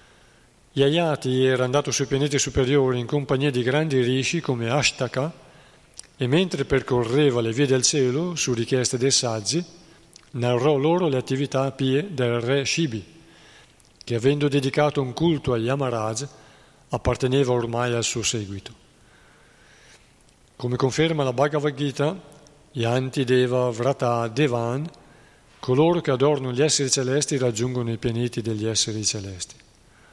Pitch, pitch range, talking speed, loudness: 135 Hz, 125-145 Hz, 130 wpm, -23 LUFS